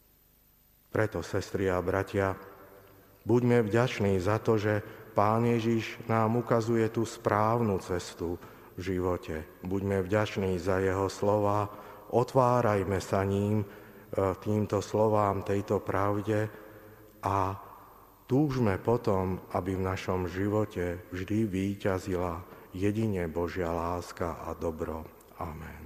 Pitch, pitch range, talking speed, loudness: 100 Hz, 90-110 Hz, 105 wpm, -30 LUFS